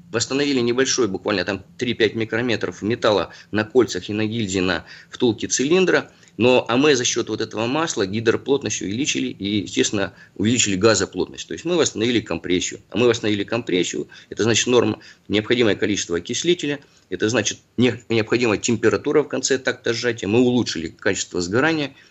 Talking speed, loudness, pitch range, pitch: 150 wpm, -20 LUFS, 100-125 Hz, 115 Hz